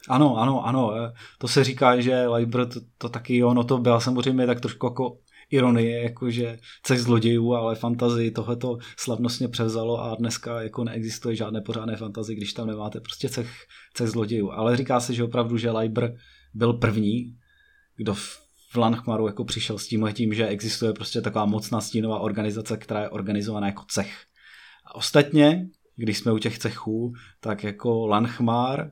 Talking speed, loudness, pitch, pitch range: 170 wpm, -25 LUFS, 115 Hz, 110-125 Hz